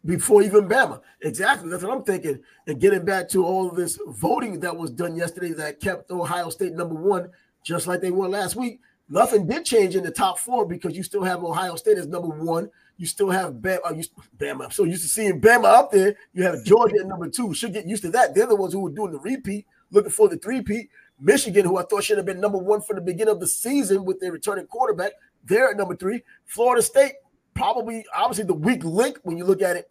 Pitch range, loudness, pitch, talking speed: 180-230 Hz, -22 LUFS, 195 Hz, 235 wpm